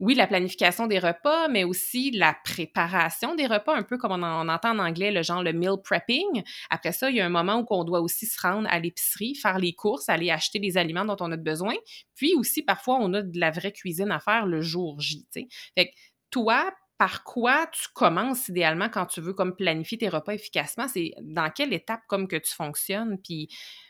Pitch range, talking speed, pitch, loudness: 170-230 Hz, 220 wpm, 195 Hz, -26 LUFS